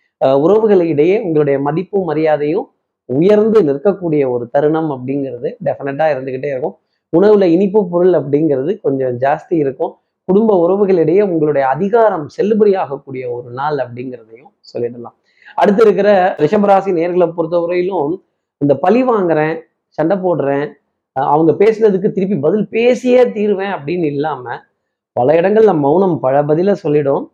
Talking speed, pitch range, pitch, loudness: 115 wpm, 145-200 Hz, 170 Hz, -14 LUFS